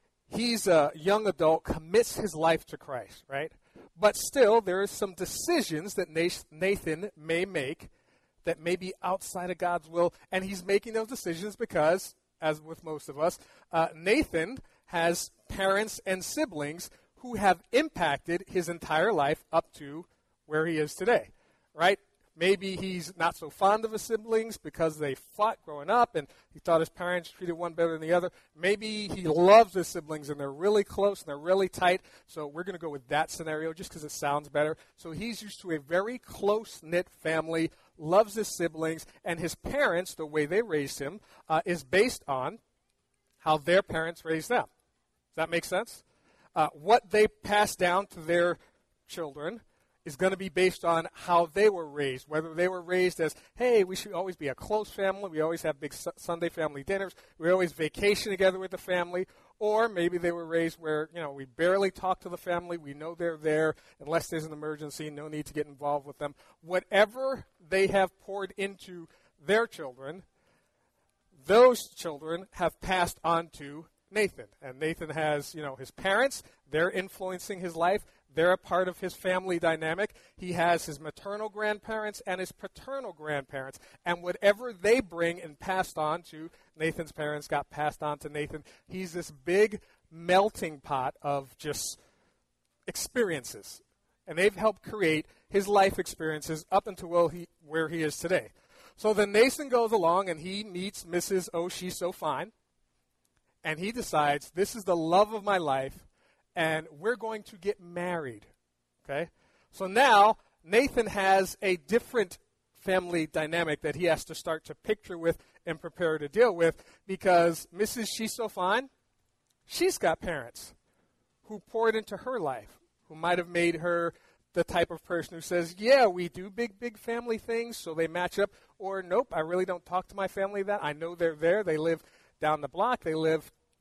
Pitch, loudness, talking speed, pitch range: 175 Hz, -29 LUFS, 180 wpm, 160-195 Hz